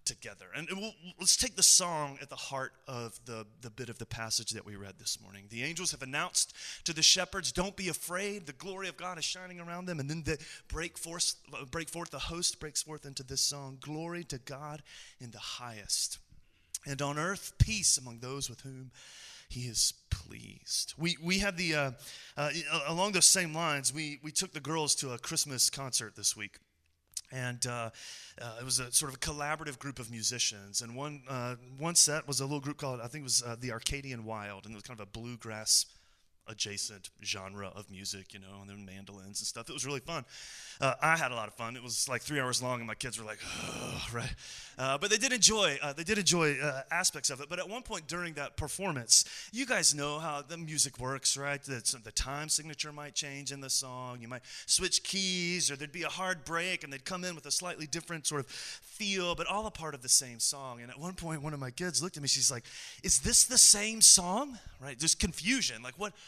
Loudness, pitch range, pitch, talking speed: -30 LUFS, 125-170 Hz, 145 Hz, 230 wpm